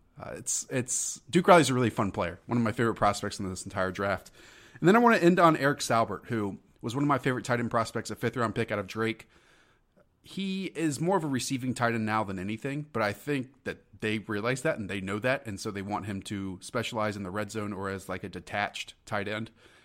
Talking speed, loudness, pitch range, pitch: 250 wpm, -29 LUFS, 100-130 Hz, 110 Hz